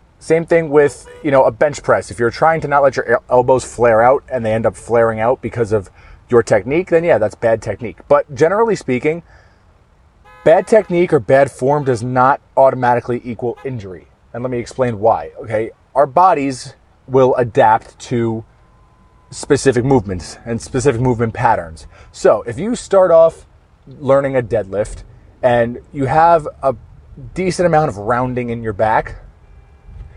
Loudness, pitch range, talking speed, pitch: -15 LUFS, 110-145 Hz, 165 wpm, 125 Hz